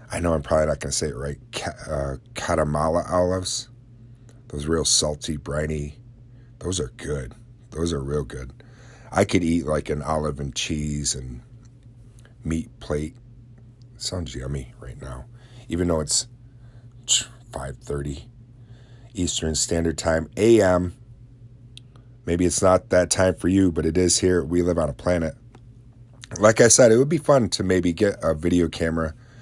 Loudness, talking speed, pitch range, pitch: -22 LUFS, 155 wpm, 80-120 Hz, 90 Hz